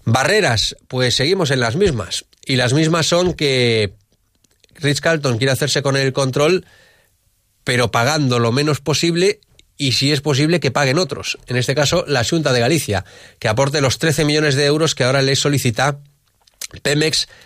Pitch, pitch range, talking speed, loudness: 140 Hz, 120-150 Hz, 170 wpm, -17 LUFS